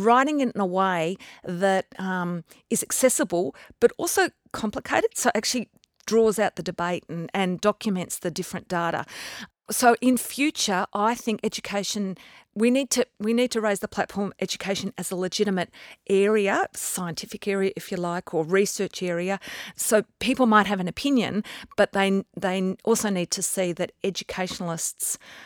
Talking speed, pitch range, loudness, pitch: 160 wpm, 185-225 Hz, -25 LUFS, 200 Hz